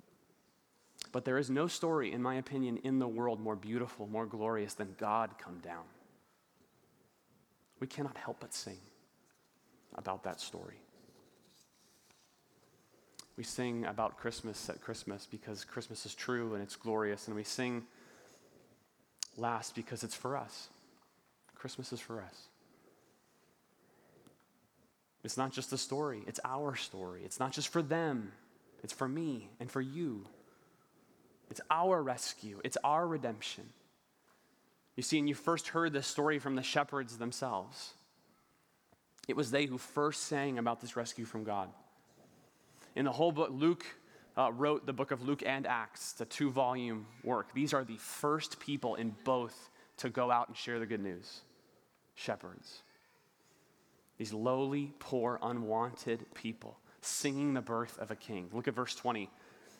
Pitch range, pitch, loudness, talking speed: 110-140 Hz, 120 Hz, -38 LUFS, 150 wpm